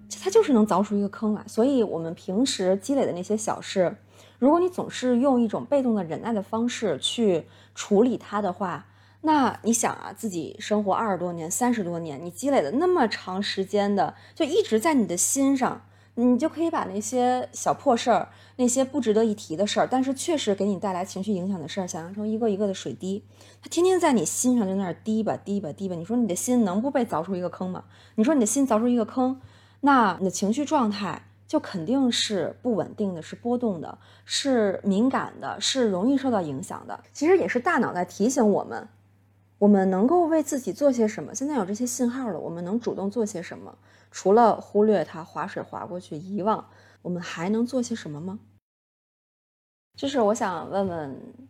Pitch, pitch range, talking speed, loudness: 215 Hz, 190-250 Hz, 305 characters per minute, -25 LUFS